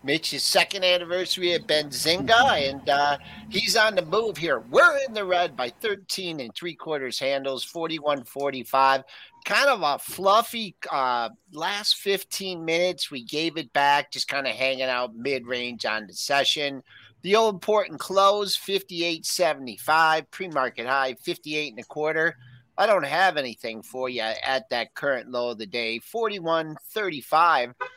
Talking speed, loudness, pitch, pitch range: 155 wpm, -24 LUFS, 155 Hz, 135-185 Hz